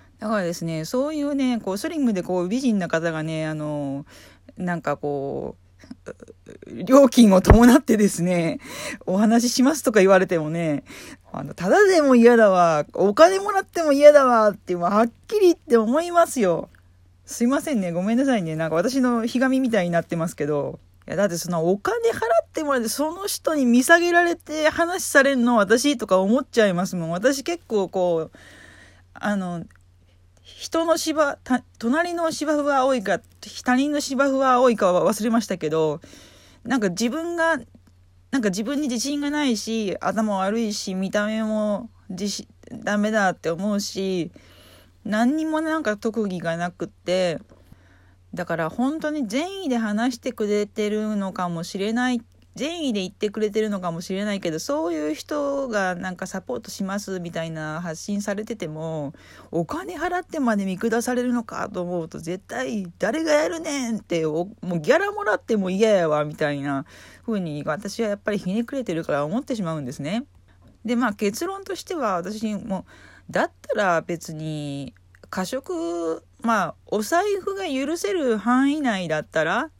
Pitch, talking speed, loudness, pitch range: 210 Hz, 325 characters per minute, -22 LUFS, 170-265 Hz